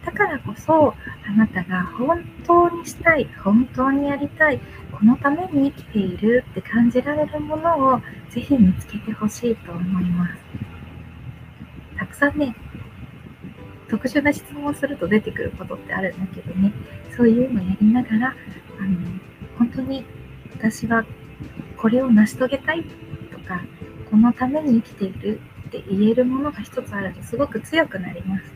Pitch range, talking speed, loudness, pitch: 205-280 Hz, 310 characters per minute, -21 LUFS, 235 Hz